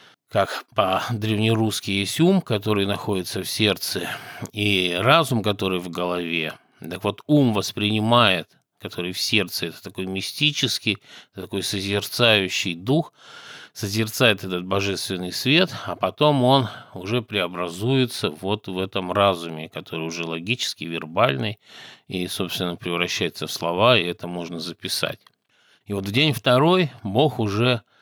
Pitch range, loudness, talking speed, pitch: 90-120 Hz, -22 LUFS, 125 wpm, 100 Hz